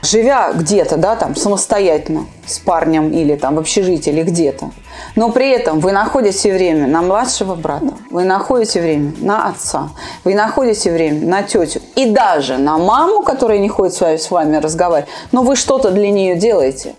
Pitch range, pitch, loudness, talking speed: 160-225 Hz, 190 Hz, -14 LUFS, 175 wpm